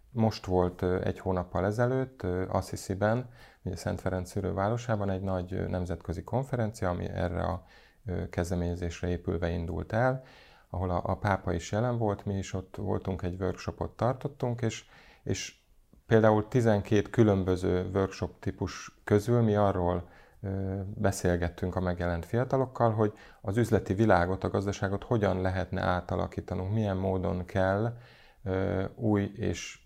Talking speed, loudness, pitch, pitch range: 125 wpm, -30 LUFS, 95 Hz, 90-110 Hz